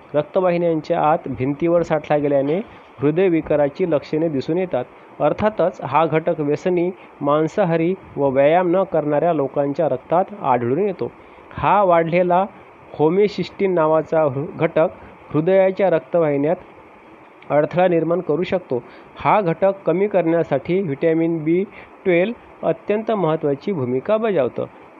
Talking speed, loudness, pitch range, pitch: 110 wpm, -19 LUFS, 150-185 Hz, 165 Hz